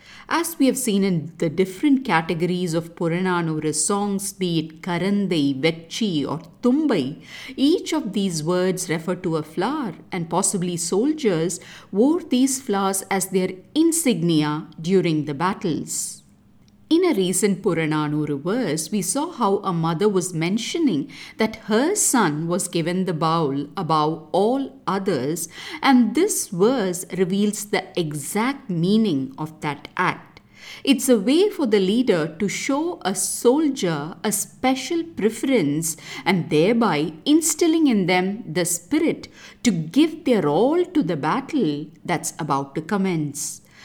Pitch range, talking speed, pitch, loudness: 165-250 Hz, 135 wpm, 190 Hz, -22 LUFS